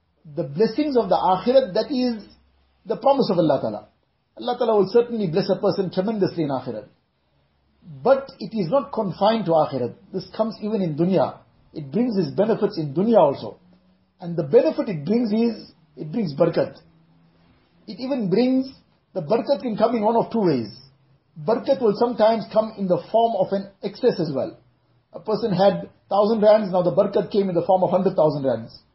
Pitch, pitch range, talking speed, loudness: 200 Hz, 165-225 Hz, 185 wpm, -21 LUFS